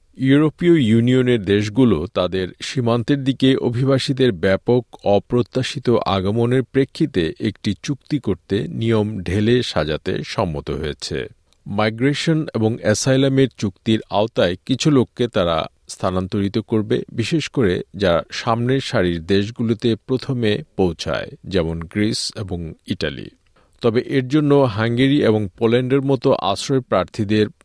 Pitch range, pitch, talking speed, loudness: 105-135 Hz, 115 Hz, 110 wpm, -19 LUFS